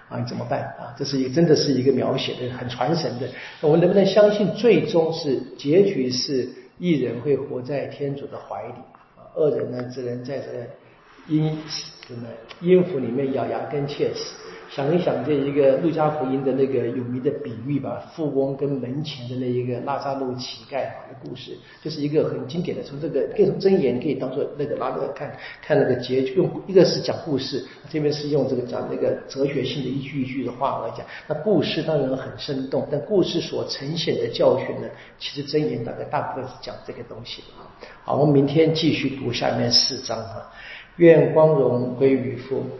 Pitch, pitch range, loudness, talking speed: 140 Hz, 130-155 Hz, -22 LUFS, 295 characters per minute